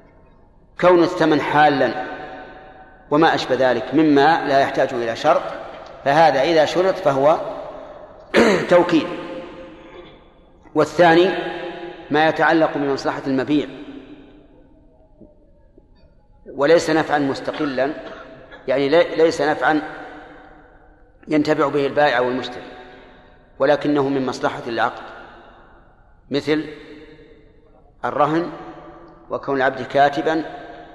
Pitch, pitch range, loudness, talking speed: 150 Hz, 140-165 Hz, -18 LUFS, 80 wpm